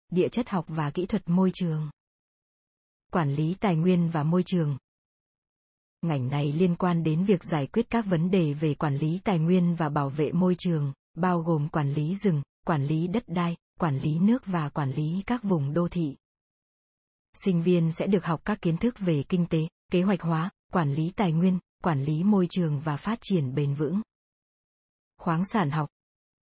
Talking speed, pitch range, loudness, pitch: 195 wpm, 155-185 Hz, -27 LUFS, 170 Hz